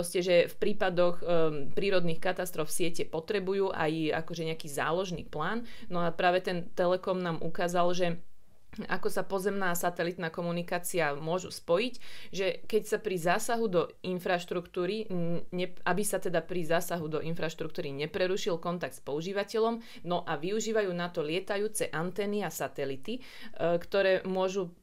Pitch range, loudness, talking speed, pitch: 170-195 Hz, -32 LUFS, 145 wpm, 180 Hz